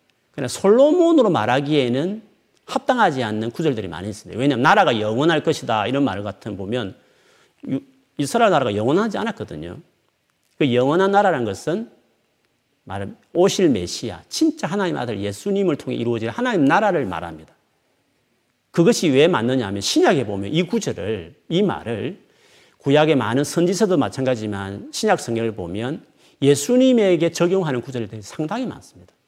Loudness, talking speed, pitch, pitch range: -20 LUFS, 350 characters per minute, 140 Hz, 115-190 Hz